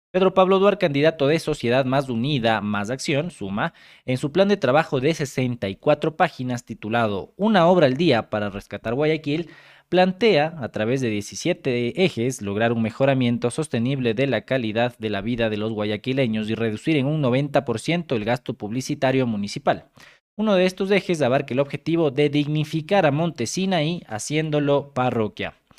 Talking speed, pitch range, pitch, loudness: 160 wpm, 115-160 Hz, 135 Hz, -22 LUFS